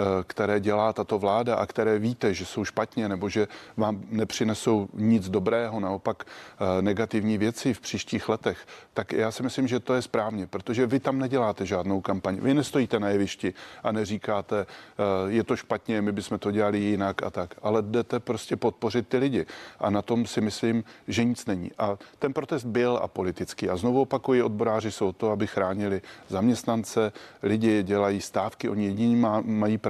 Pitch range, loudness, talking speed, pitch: 100-115 Hz, -27 LUFS, 175 wpm, 110 Hz